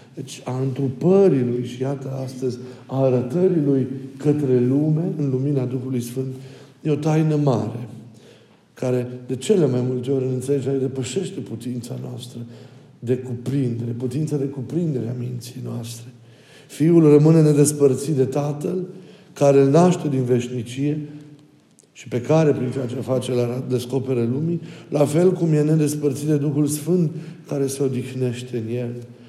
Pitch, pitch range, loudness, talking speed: 135 Hz, 125-150 Hz, -21 LUFS, 150 wpm